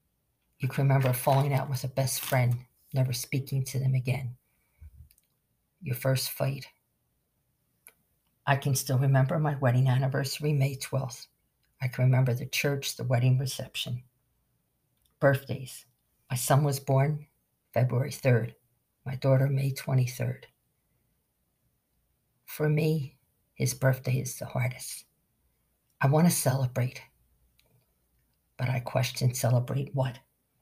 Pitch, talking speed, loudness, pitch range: 130 Hz, 120 wpm, -28 LUFS, 125-135 Hz